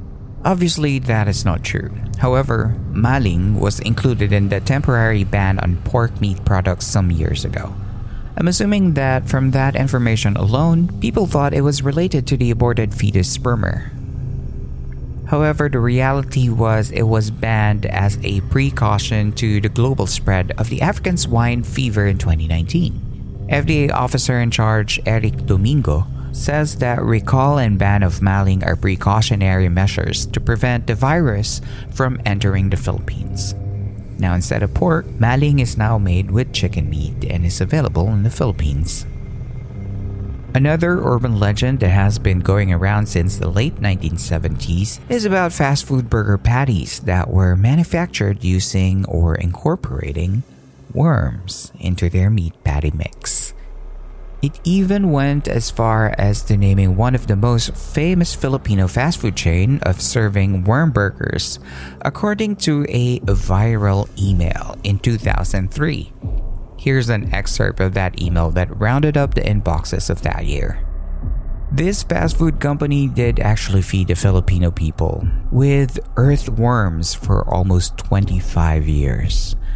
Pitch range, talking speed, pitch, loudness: 95-125 Hz, 140 wpm, 105 Hz, -18 LUFS